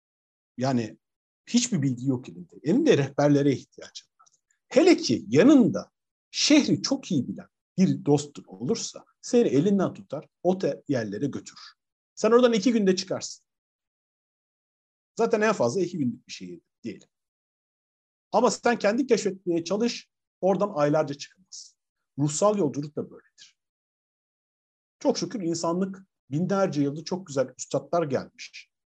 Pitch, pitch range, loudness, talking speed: 180 Hz, 140-230 Hz, -25 LUFS, 125 wpm